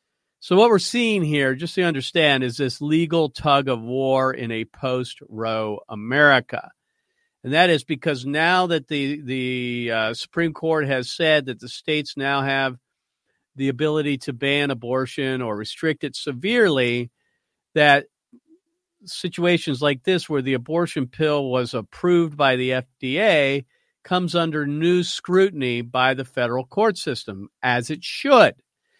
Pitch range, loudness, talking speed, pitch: 130-170 Hz, -21 LUFS, 145 wpm, 145 Hz